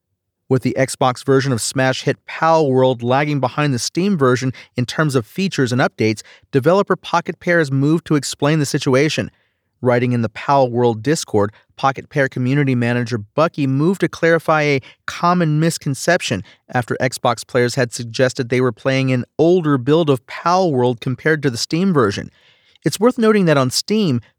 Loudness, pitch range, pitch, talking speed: -17 LUFS, 125-160 Hz, 135 Hz, 170 wpm